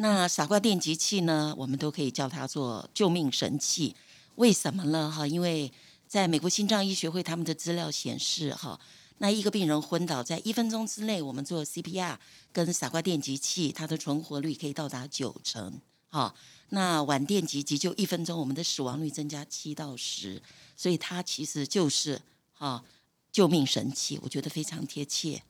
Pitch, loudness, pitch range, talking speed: 155 Hz, -30 LUFS, 145-180 Hz, 280 characters per minute